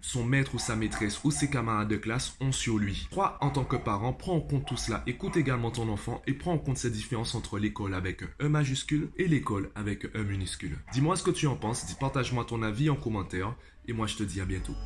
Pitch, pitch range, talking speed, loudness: 120 Hz, 105-135 Hz, 250 wpm, -31 LUFS